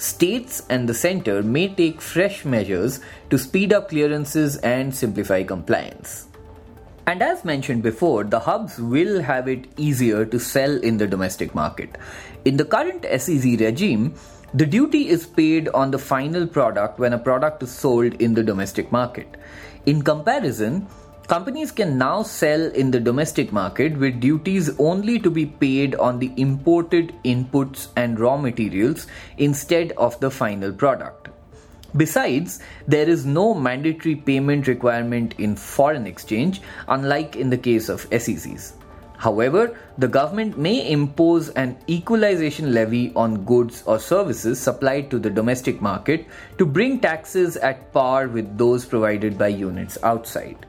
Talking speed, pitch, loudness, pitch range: 150 wpm, 135 Hz, -21 LUFS, 115-155 Hz